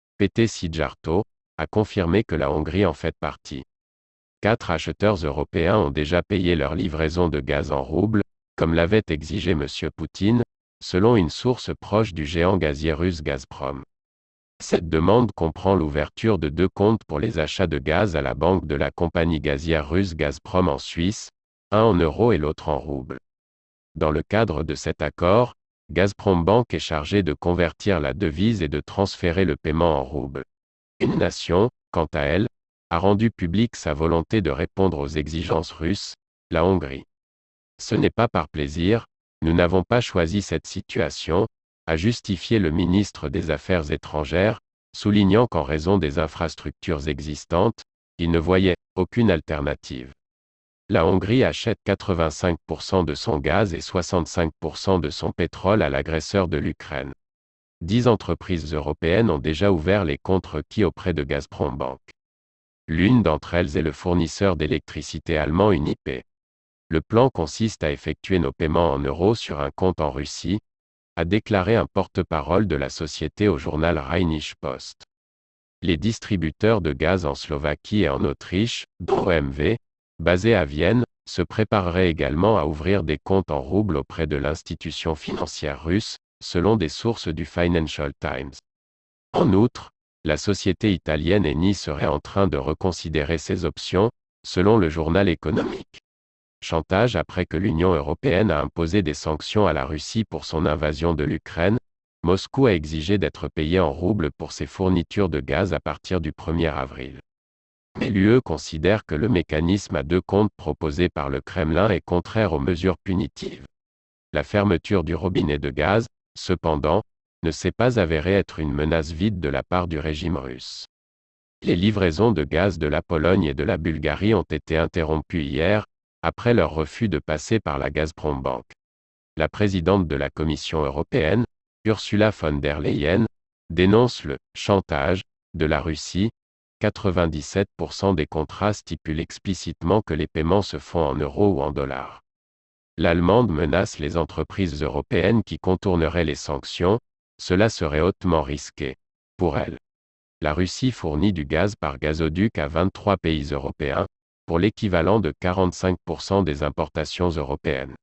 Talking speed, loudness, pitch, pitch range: 155 wpm, -23 LUFS, 85 Hz, 75-95 Hz